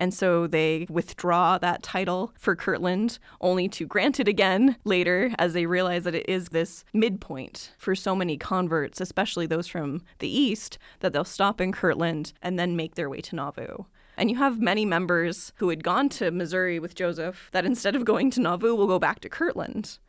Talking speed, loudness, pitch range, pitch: 195 wpm, -26 LUFS, 170-205 Hz, 180 Hz